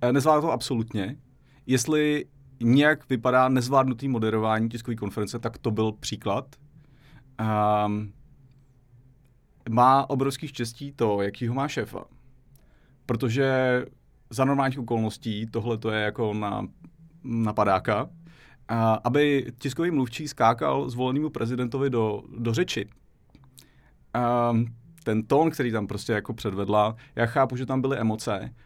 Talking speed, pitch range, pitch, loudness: 115 wpm, 115-135 Hz, 125 Hz, -26 LUFS